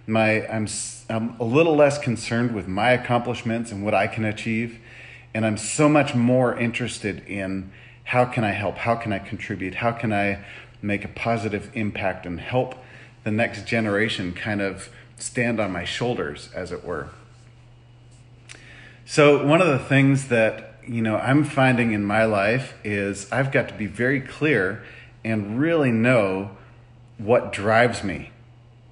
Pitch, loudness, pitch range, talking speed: 115 Hz, -22 LUFS, 105-125 Hz, 160 wpm